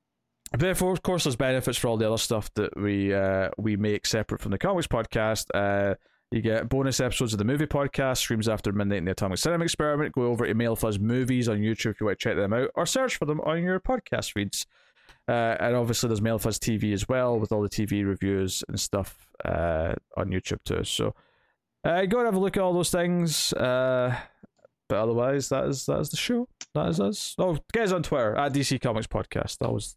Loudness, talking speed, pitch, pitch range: -27 LUFS, 225 wpm, 120 Hz, 105-150 Hz